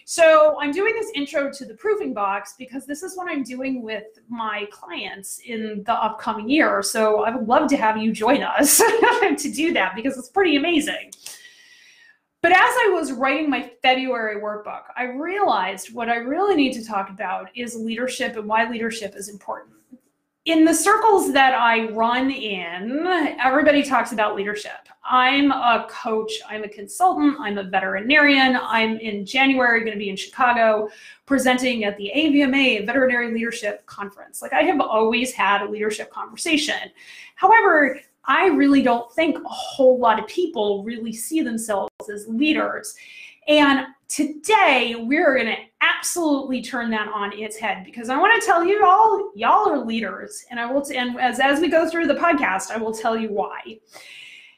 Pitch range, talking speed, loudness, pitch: 220-315 Hz, 175 wpm, -20 LUFS, 255 Hz